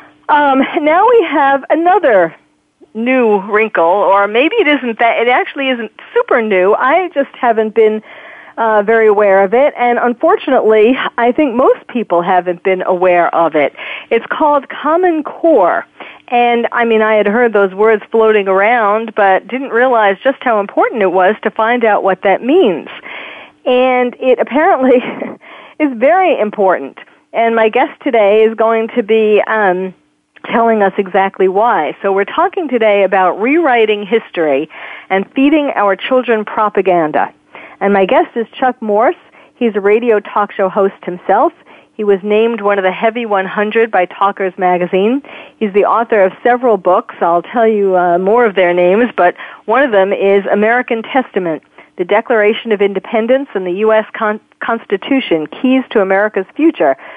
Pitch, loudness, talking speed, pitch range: 220 Hz, -12 LUFS, 160 wpm, 200-255 Hz